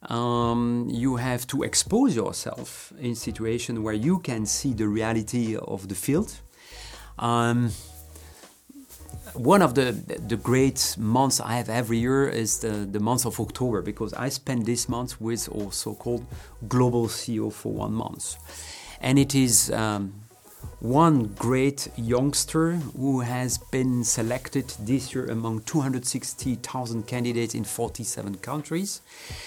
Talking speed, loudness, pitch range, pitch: 135 wpm, -25 LUFS, 110-130 Hz, 120 Hz